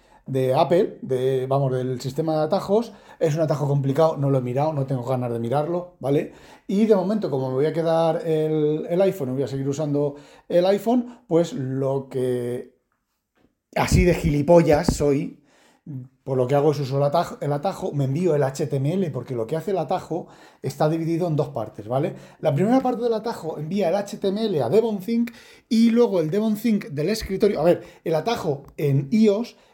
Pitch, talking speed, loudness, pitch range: 160 Hz, 190 wpm, -22 LUFS, 140-195 Hz